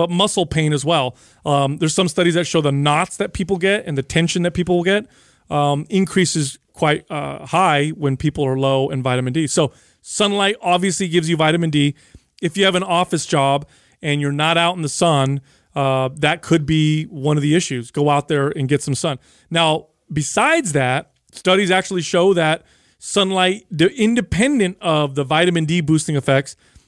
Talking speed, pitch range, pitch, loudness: 190 wpm, 145-180 Hz, 160 Hz, -18 LUFS